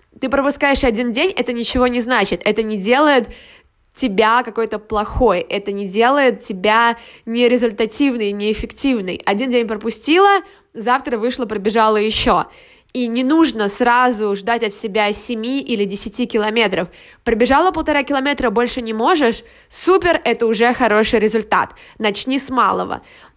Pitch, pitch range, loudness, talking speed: 235 Hz, 220-255 Hz, -16 LUFS, 135 wpm